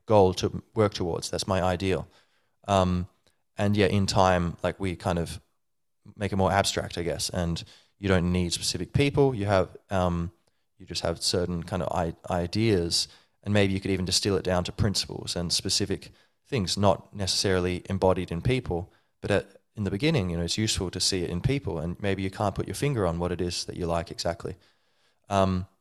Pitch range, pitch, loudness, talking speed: 90-100 Hz, 95 Hz, -27 LUFS, 200 wpm